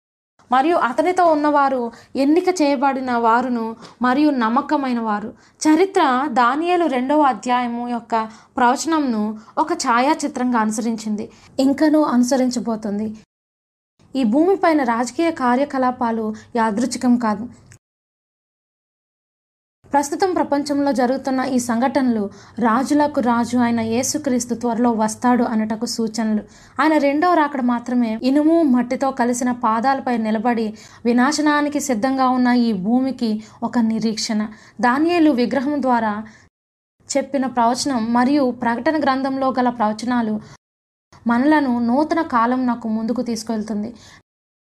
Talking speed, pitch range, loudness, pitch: 100 wpm, 230-280 Hz, -19 LUFS, 245 Hz